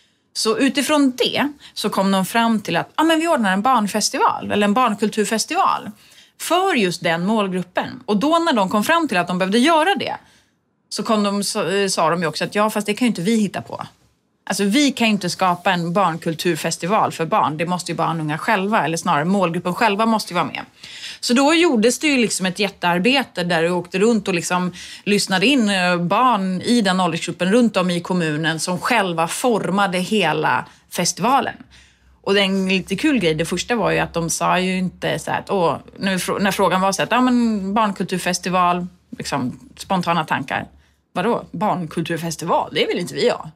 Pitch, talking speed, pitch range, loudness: 195 Hz, 195 wpm, 175-225 Hz, -19 LUFS